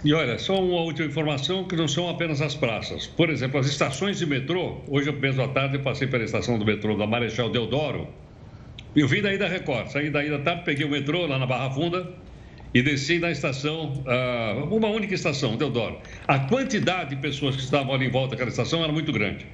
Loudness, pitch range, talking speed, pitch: -25 LUFS, 125-165 Hz, 210 wpm, 145 Hz